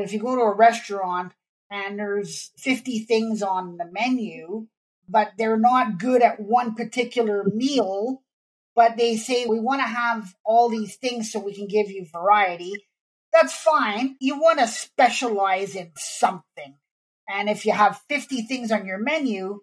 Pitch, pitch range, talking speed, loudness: 220 Hz, 200-245 Hz, 165 wpm, -22 LUFS